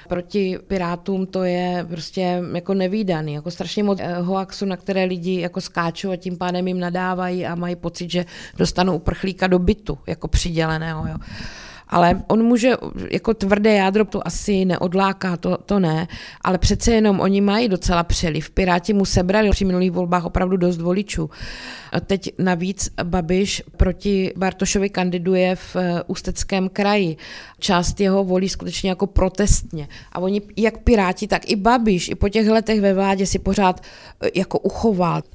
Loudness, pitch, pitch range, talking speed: -20 LUFS, 185 Hz, 175-195 Hz, 160 wpm